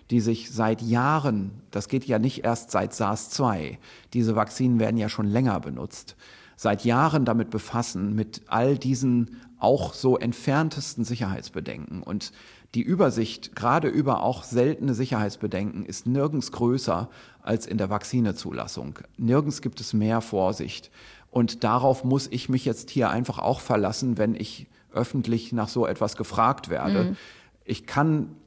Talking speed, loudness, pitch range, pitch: 145 wpm, -26 LUFS, 110-130 Hz, 120 Hz